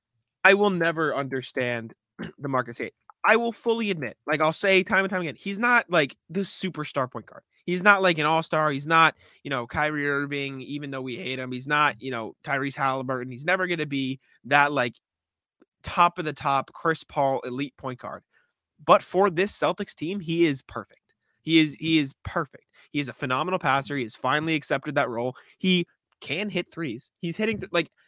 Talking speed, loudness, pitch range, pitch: 200 wpm, -25 LUFS, 135-180 Hz, 150 Hz